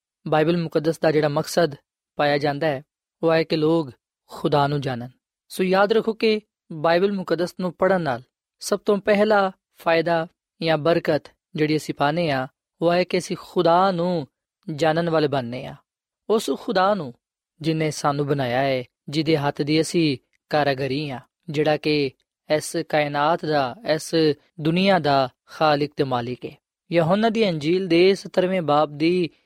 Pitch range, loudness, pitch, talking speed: 145-180 Hz, -22 LUFS, 160 Hz, 115 wpm